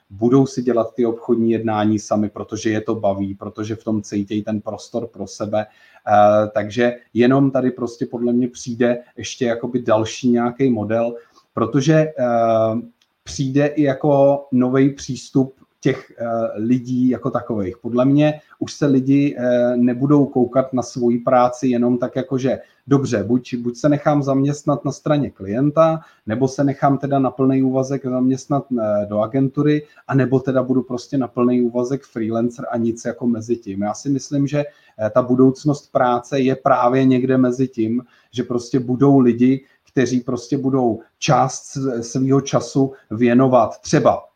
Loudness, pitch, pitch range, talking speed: -19 LUFS, 125 Hz, 115-135 Hz, 150 wpm